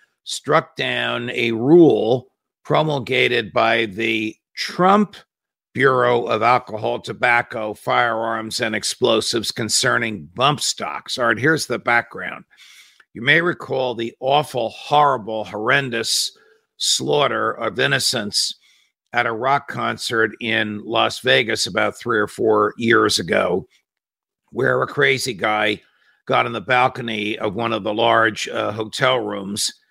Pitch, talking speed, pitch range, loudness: 115 Hz, 125 wpm, 110-125 Hz, -19 LUFS